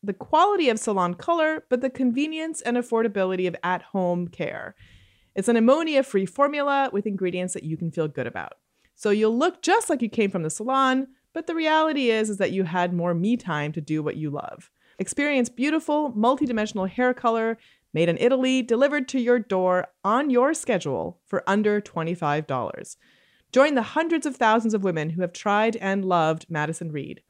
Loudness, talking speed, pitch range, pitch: -24 LUFS, 180 wpm, 180-265 Hz, 220 Hz